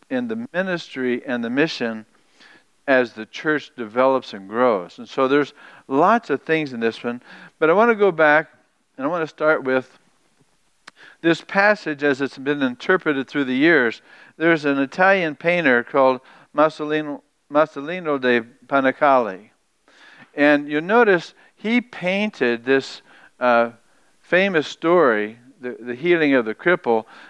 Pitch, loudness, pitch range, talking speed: 145 Hz, -20 LUFS, 125-170 Hz, 145 wpm